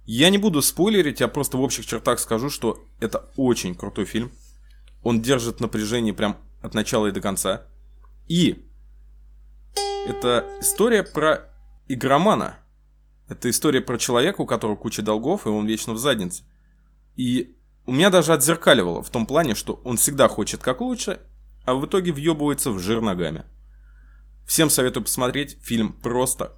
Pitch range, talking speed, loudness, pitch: 100-145 Hz, 155 wpm, -22 LUFS, 120 Hz